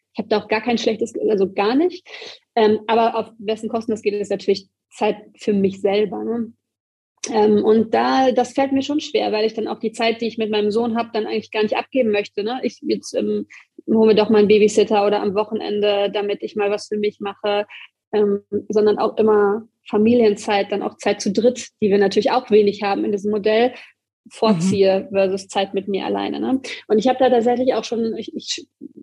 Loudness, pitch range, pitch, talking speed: -19 LUFS, 205-235 Hz, 215 Hz, 215 wpm